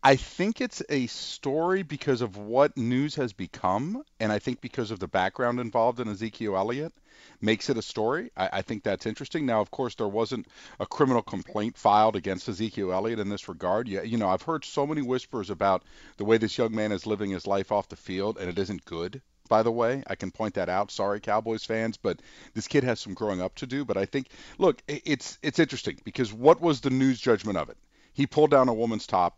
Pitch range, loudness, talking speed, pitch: 105-135 Hz, -28 LUFS, 230 wpm, 115 Hz